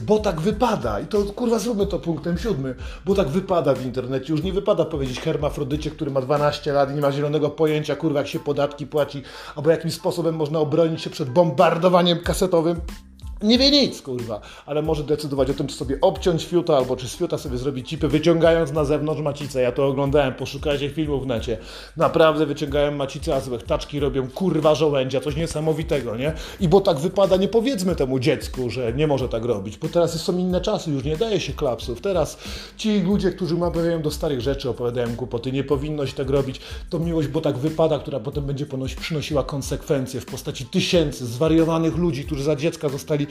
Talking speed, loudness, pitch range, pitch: 195 wpm, -22 LUFS, 140-170 Hz, 155 Hz